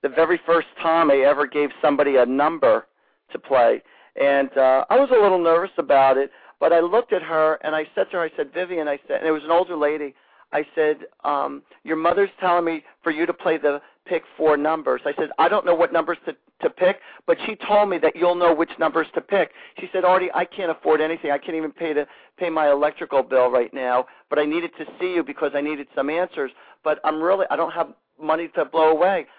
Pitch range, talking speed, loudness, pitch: 145-175 Hz, 240 wpm, -21 LUFS, 160 Hz